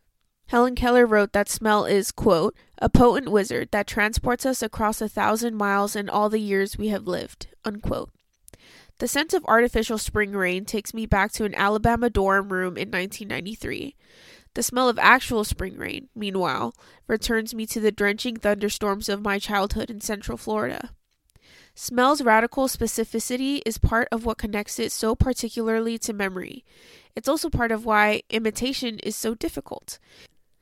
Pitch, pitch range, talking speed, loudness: 220 Hz, 205-235 Hz, 160 wpm, -23 LUFS